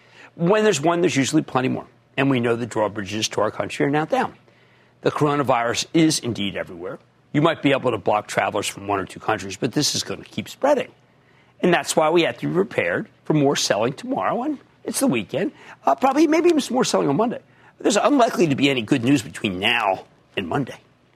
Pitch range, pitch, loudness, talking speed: 120-185 Hz, 145 Hz, -21 LUFS, 220 wpm